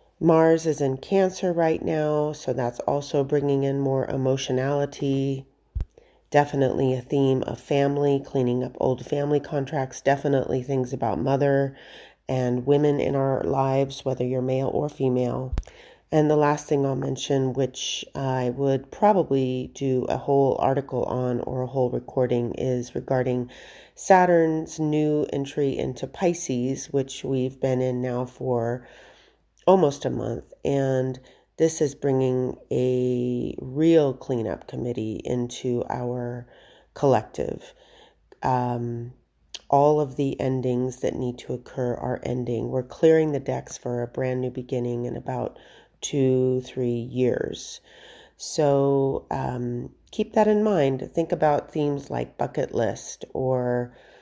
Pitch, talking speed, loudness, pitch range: 135 Hz, 135 wpm, -25 LUFS, 125-145 Hz